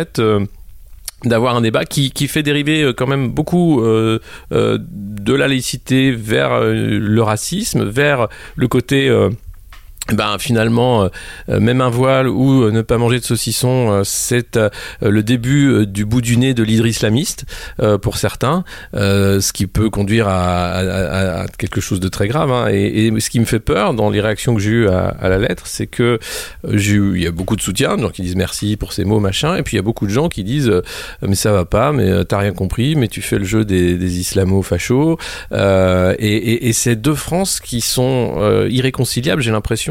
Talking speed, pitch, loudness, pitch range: 215 wpm, 110 Hz, -15 LUFS, 100-125 Hz